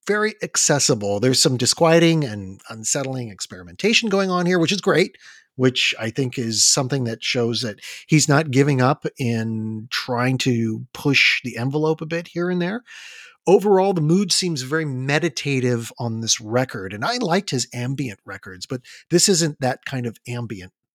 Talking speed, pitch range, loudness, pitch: 170 wpm, 120-165 Hz, -20 LUFS, 130 Hz